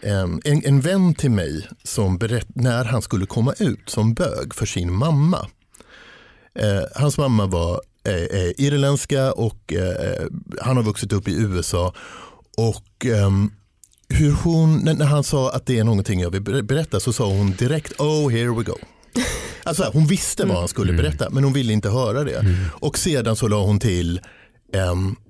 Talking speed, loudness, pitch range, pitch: 175 wpm, -20 LUFS, 100-135 Hz, 115 Hz